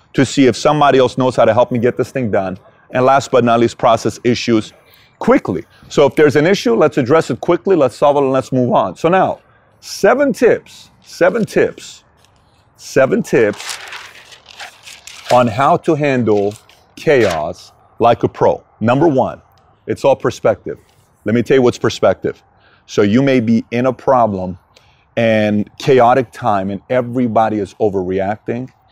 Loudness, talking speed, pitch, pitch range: -14 LUFS, 165 wpm, 125 Hz, 110-135 Hz